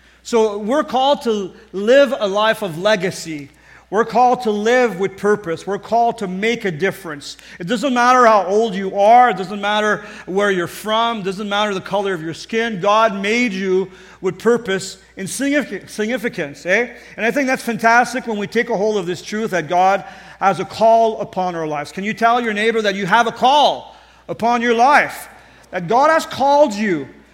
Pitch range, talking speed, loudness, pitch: 190-235 Hz, 195 wpm, -17 LUFS, 210 Hz